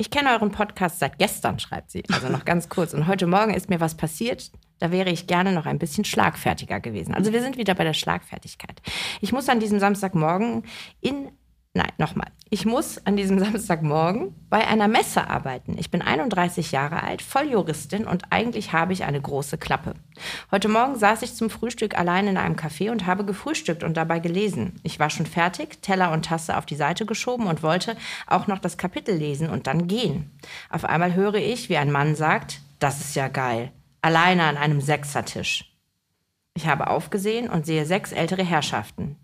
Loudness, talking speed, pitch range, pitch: -24 LUFS, 195 wpm, 160-210 Hz, 180 Hz